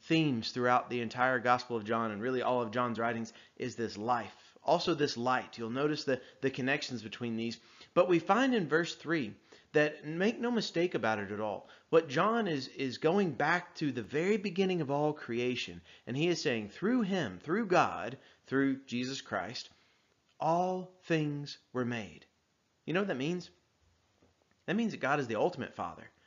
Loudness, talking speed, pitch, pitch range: -33 LUFS, 185 wpm, 135 Hz, 115-165 Hz